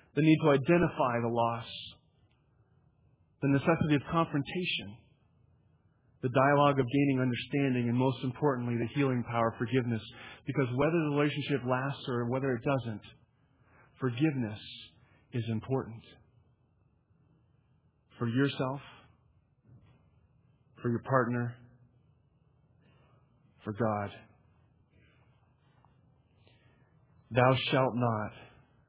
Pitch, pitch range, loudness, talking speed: 130 Hz, 120-140 Hz, -31 LUFS, 95 wpm